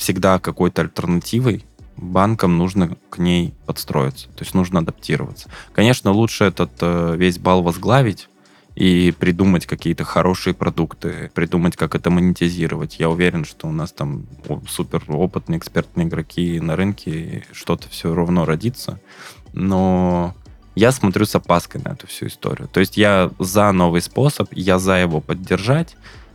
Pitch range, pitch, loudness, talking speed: 85-100 Hz, 90 Hz, -18 LUFS, 145 wpm